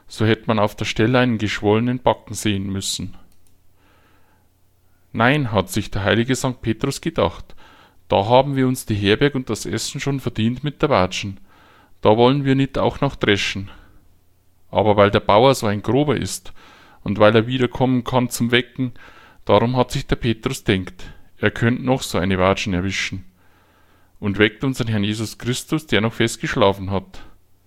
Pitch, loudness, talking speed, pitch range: 105 Hz, -19 LUFS, 170 wpm, 95-125 Hz